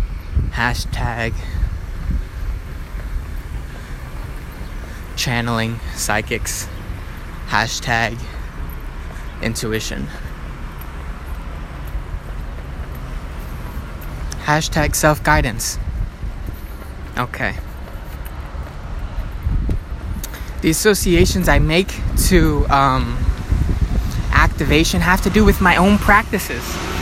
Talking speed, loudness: 50 wpm, -19 LUFS